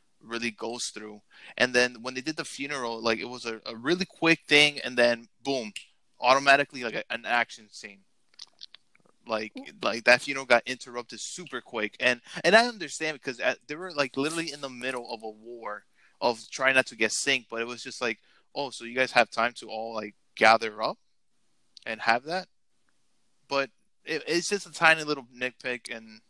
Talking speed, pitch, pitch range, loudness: 195 wpm, 125 Hz, 115-145 Hz, -27 LUFS